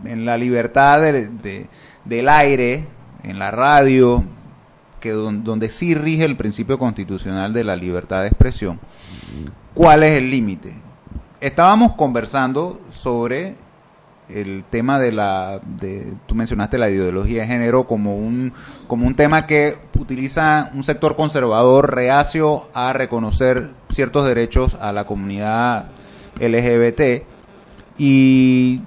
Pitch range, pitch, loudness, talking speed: 110-140 Hz, 125 Hz, -17 LUFS, 125 wpm